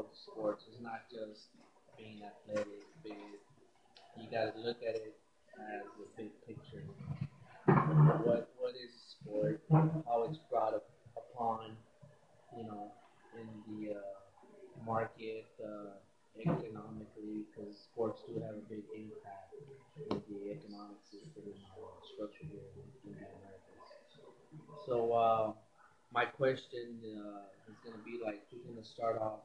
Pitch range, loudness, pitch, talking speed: 105-120 Hz, -38 LUFS, 110 Hz, 130 wpm